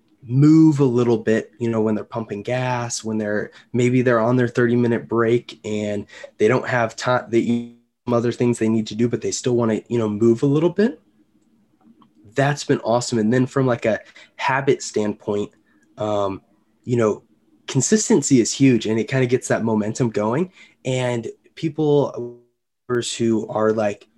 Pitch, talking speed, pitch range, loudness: 120 Hz, 180 wpm, 110-125 Hz, -20 LUFS